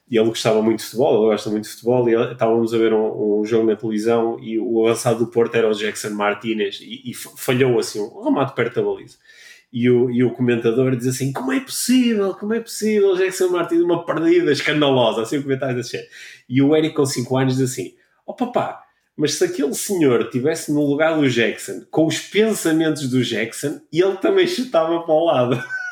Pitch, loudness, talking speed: 135 Hz, -19 LUFS, 210 wpm